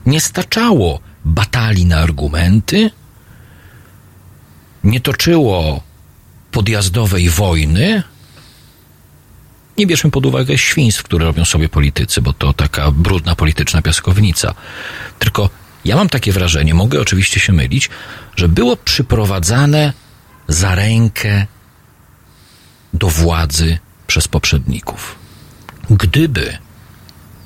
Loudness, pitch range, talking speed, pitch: -13 LUFS, 80-115 Hz, 95 wpm, 95 Hz